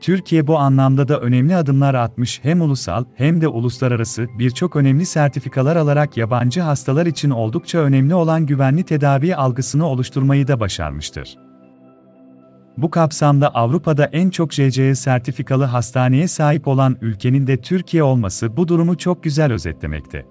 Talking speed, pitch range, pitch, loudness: 140 wpm, 120-155 Hz, 135 Hz, -17 LUFS